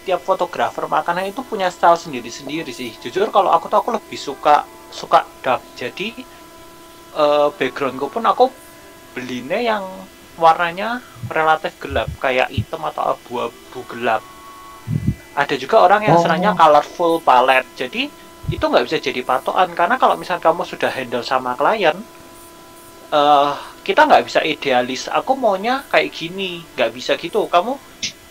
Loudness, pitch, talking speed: -18 LUFS, 175 Hz, 140 wpm